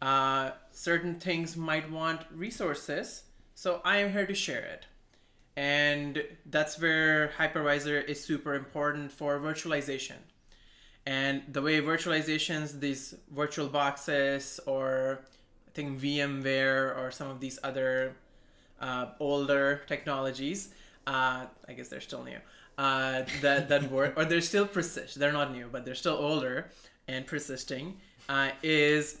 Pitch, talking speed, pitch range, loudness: 145 Hz, 135 wpm, 135-155 Hz, -31 LUFS